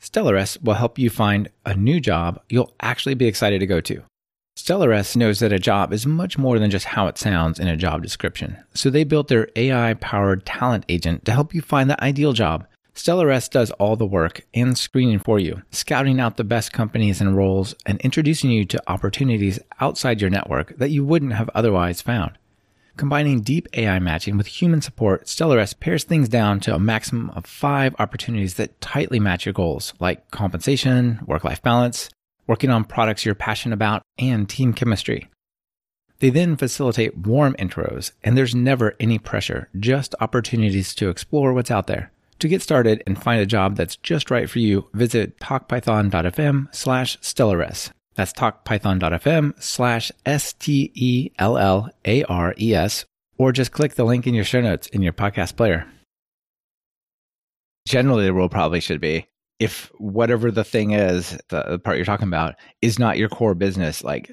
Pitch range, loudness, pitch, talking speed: 100-130 Hz, -20 LUFS, 110 Hz, 180 wpm